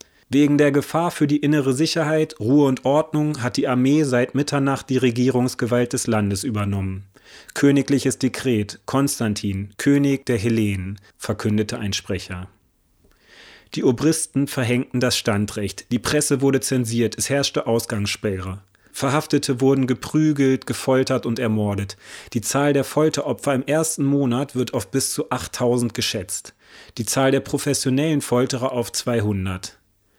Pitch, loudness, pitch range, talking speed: 125 Hz, -21 LUFS, 110-140 Hz, 135 wpm